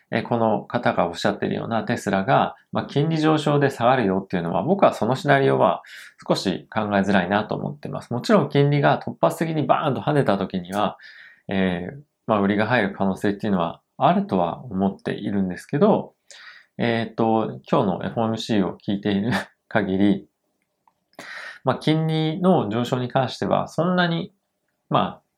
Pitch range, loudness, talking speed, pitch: 100-140 Hz, -22 LUFS, 350 characters per minute, 110 Hz